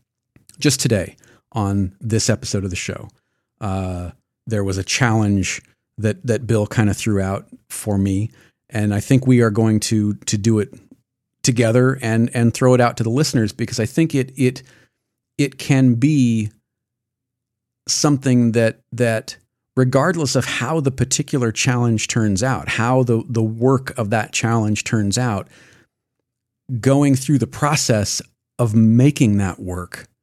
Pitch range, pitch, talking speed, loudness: 110-130 Hz, 120 Hz, 155 wpm, -18 LUFS